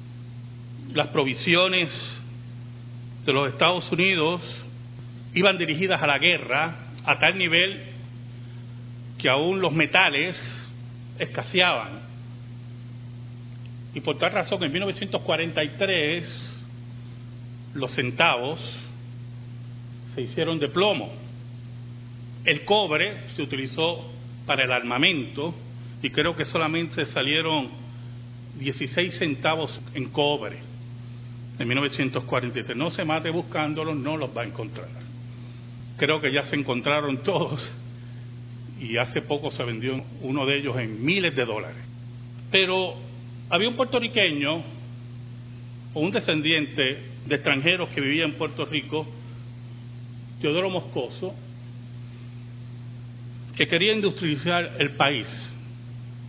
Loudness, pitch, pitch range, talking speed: -24 LUFS, 125 Hz, 120-155 Hz, 105 wpm